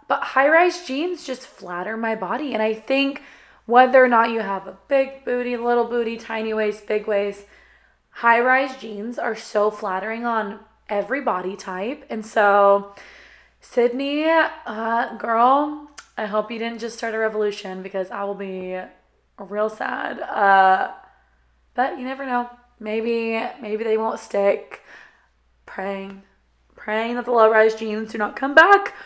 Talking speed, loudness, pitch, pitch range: 155 wpm, -21 LUFS, 225 Hz, 210-250 Hz